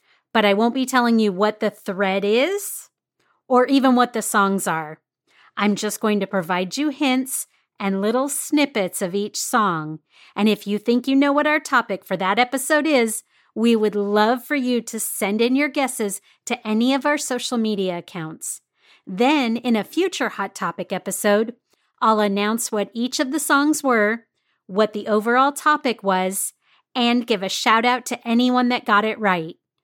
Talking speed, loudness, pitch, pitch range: 180 wpm, -20 LUFS, 225 Hz, 205-255 Hz